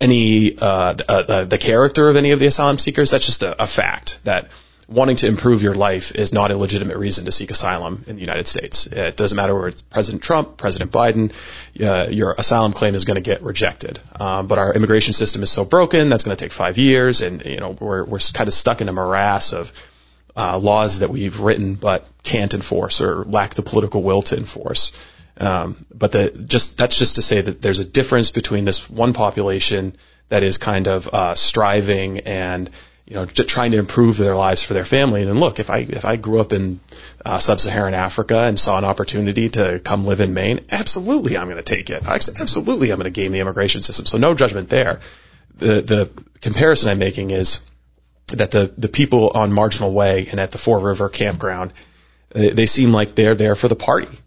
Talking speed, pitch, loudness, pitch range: 215 wpm, 105 Hz, -16 LUFS, 95-115 Hz